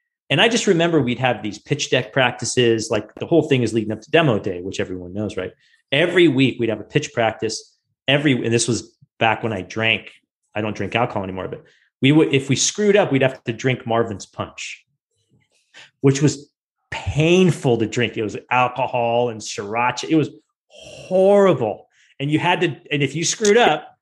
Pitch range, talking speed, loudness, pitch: 115-150 Hz, 195 wpm, -19 LUFS, 130 Hz